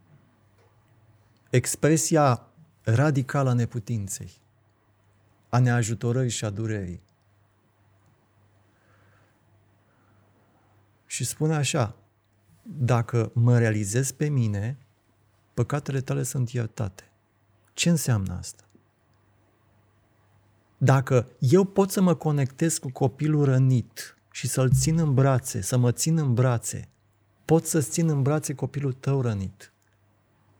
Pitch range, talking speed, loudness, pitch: 105-135 Hz, 100 wpm, -25 LUFS, 115 Hz